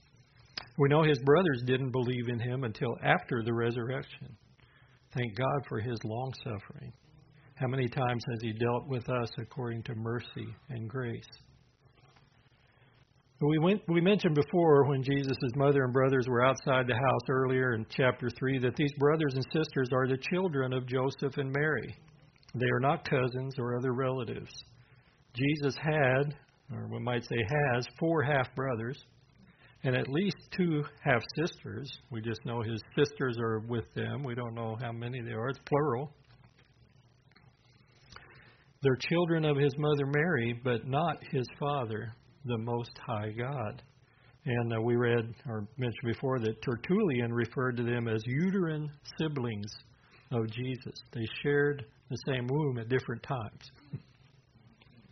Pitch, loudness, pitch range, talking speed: 130 Hz, -31 LUFS, 120-140 Hz, 150 wpm